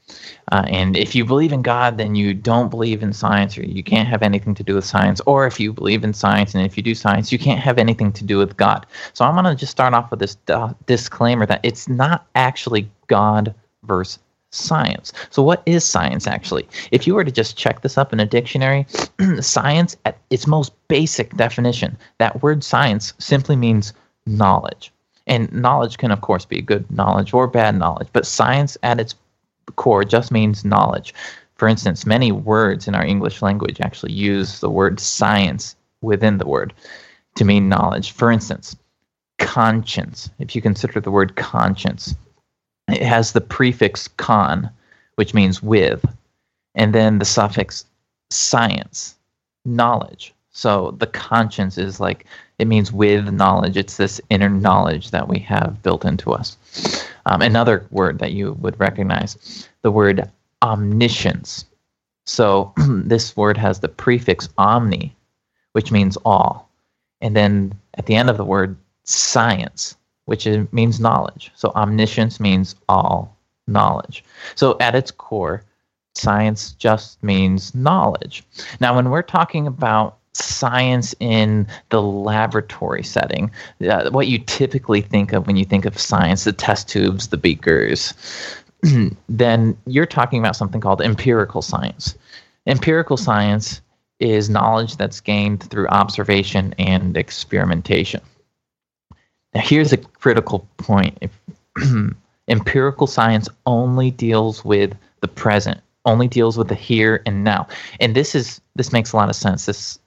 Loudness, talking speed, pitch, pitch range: -17 LUFS, 155 wpm, 110 Hz, 100-120 Hz